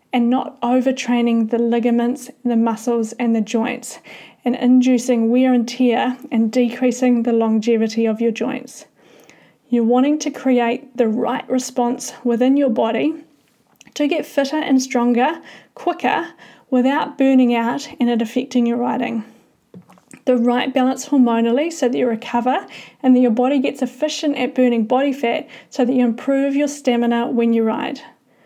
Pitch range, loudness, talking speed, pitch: 235-265 Hz, -18 LUFS, 155 wpm, 245 Hz